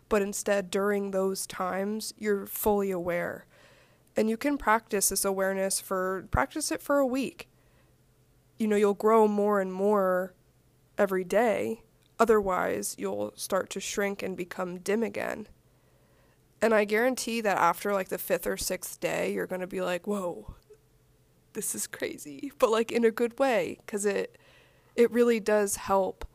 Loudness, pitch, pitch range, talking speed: -28 LUFS, 205 Hz, 190-225 Hz, 160 wpm